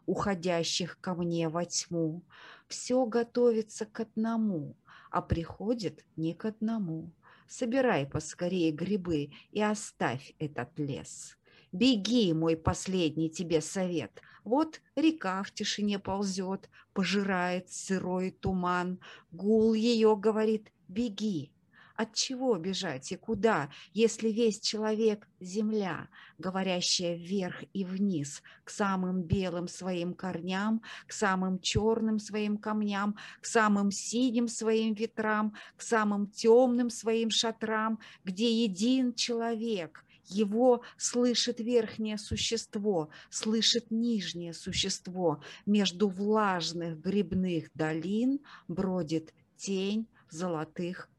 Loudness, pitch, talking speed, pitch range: -31 LUFS, 200 Hz, 105 wpm, 175-225 Hz